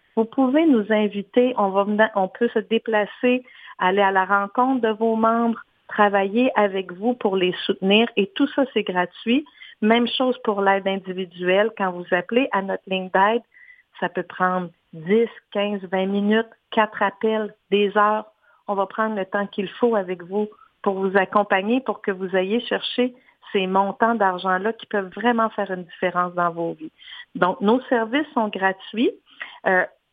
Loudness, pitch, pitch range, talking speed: -22 LUFS, 210 Hz, 195-235 Hz, 175 wpm